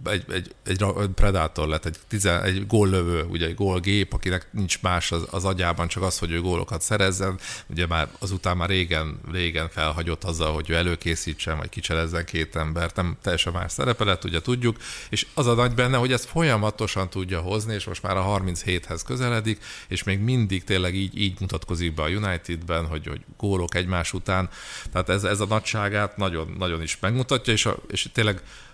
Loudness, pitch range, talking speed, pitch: -25 LUFS, 85-105 Hz, 185 wpm, 95 Hz